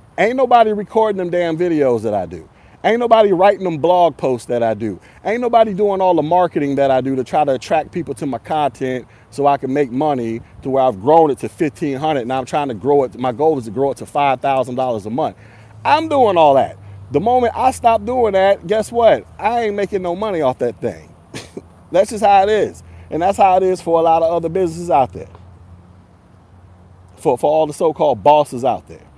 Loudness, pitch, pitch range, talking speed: -16 LUFS, 150 Hz, 125-195 Hz, 225 wpm